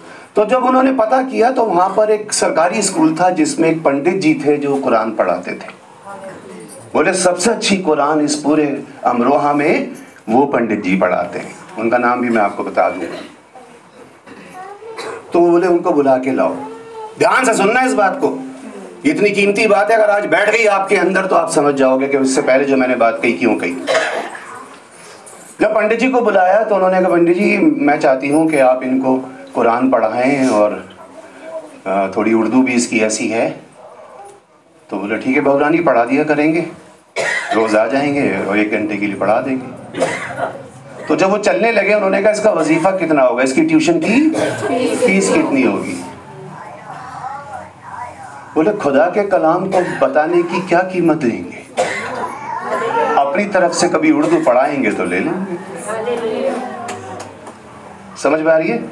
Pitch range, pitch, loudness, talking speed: 140-220 Hz, 175 Hz, -14 LUFS, 165 wpm